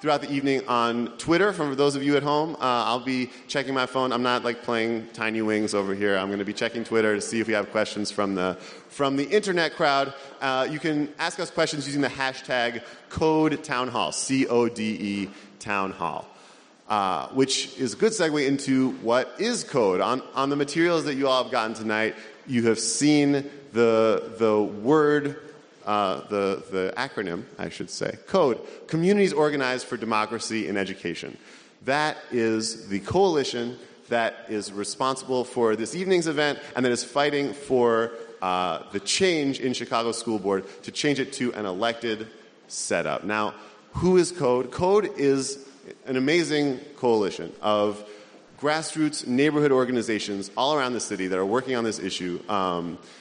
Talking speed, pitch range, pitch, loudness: 170 wpm, 105-145 Hz, 125 Hz, -25 LUFS